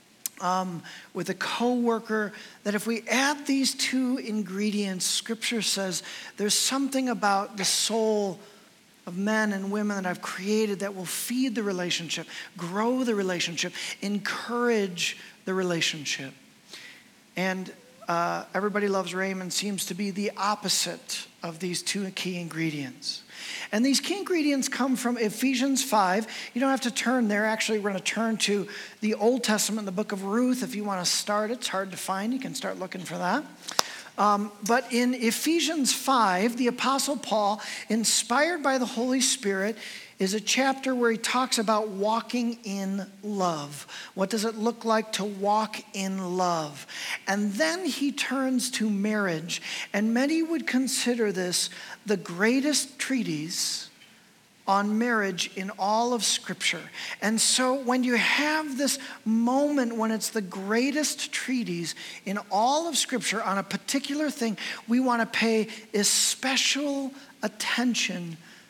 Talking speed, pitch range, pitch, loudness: 150 wpm, 195-250 Hz, 215 Hz, -27 LUFS